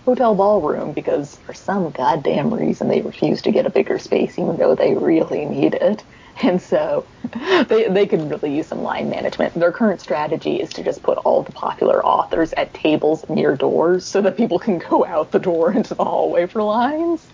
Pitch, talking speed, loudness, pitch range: 200 Hz, 200 wpm, -18 LUFS, 175-240 Hz